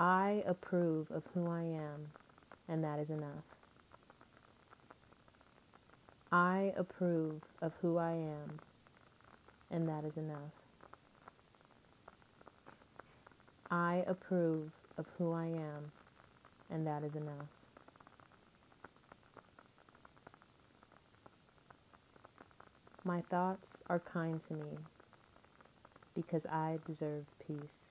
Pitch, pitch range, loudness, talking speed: 160 Hz, 150-175 Hz, -40 LUFS, 85 wpm